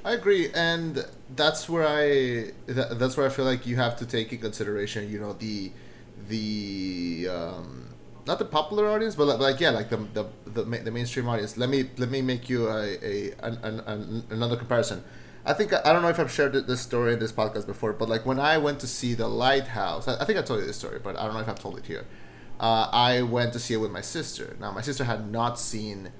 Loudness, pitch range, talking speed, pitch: -27 LUFS, 110-135 Hz, 240 wpm, 120 Hz